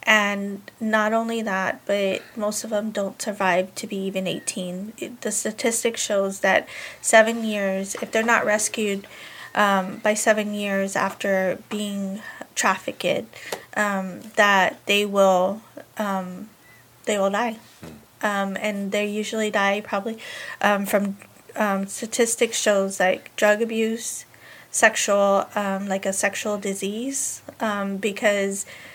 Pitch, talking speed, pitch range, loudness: 205 Hz, 130 wpm, 195-220 Hz, -23 LUFS